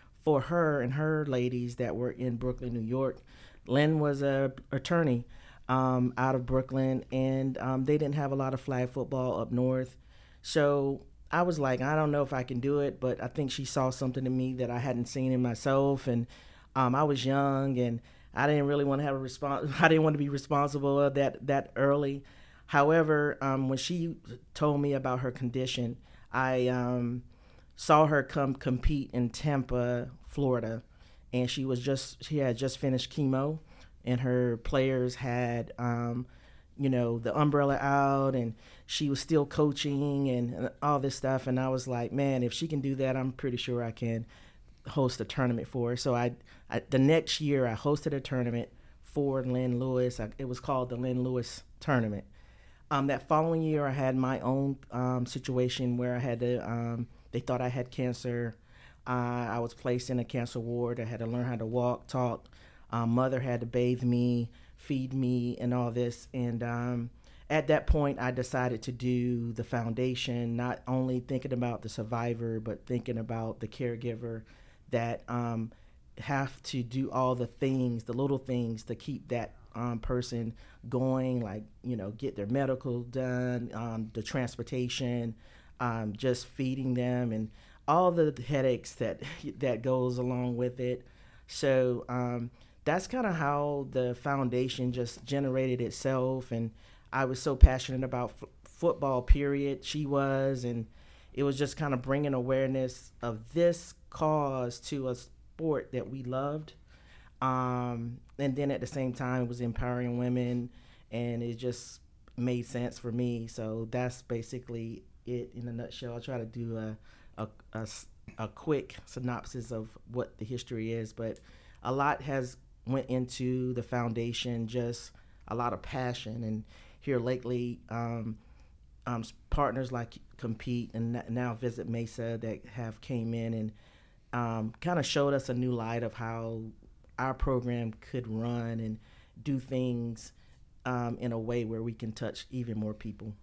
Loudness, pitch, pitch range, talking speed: -32 LUFS, 125 Hz, 120-135 Hz, 175 wpm